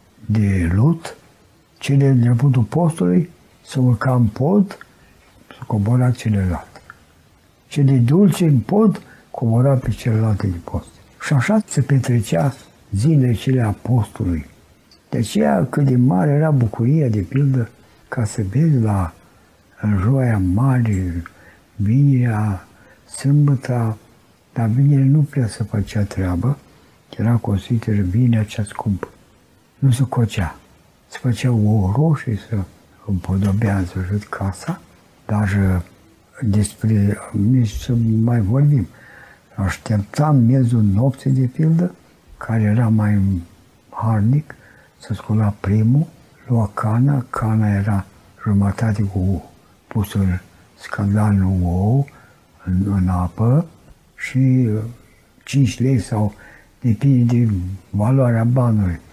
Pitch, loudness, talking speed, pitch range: 110 Hz, -18 LUFS, 110 wpm, 100-130 Hz